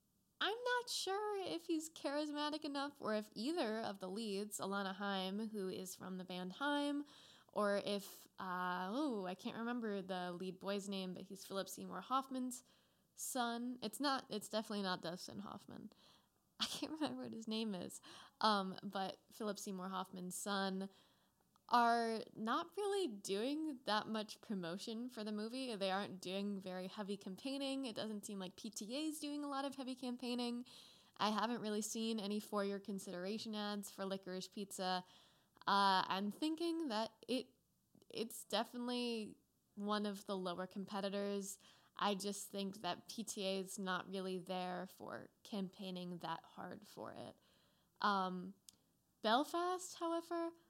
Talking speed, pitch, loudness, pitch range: 150 wpm, 210 Hz, -43 LUFS, 195-250 Hz